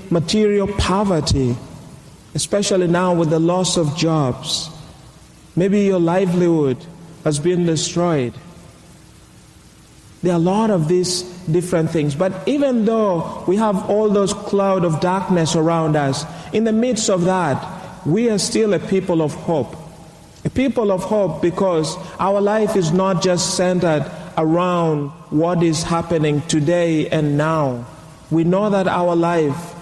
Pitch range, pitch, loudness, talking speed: 160-190 Hz, 175 Hz, -18 LUFS, 140 wpm